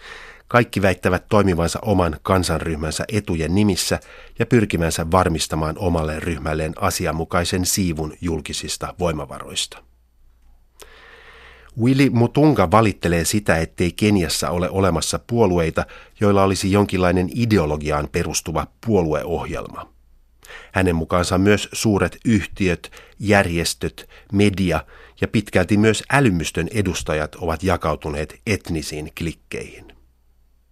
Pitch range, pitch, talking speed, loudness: 80-100 Hz, 90 Hz, 90 wpm, -20 LUFS